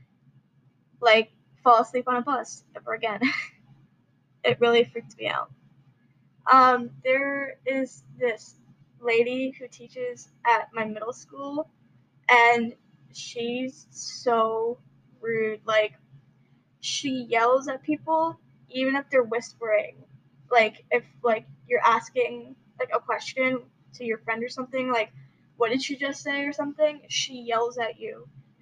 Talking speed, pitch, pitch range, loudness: 130 wpm, 235 Hz, 215-260 Hz, -25 LUFS